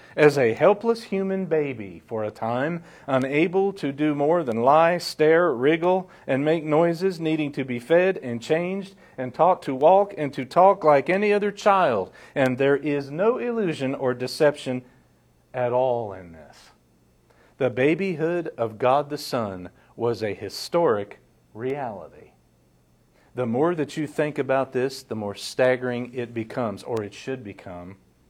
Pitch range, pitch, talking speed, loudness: 120-170 Hz, 140 Hz, 155 wpm, -23 LUFS